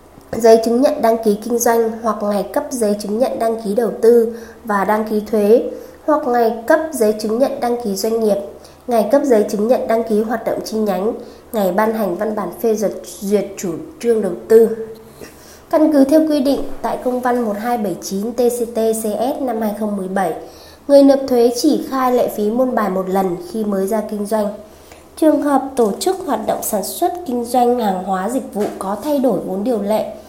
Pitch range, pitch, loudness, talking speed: 210-250 Hz, 225 Hz, -17 LUFS, 200 wpm